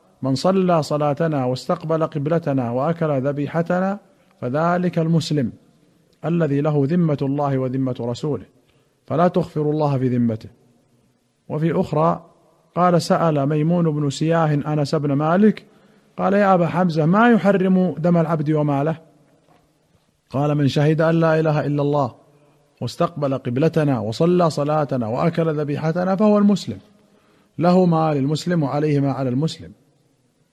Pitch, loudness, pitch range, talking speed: 155 Hz, -19 LUFS, 140-170 Hz, 120 wpm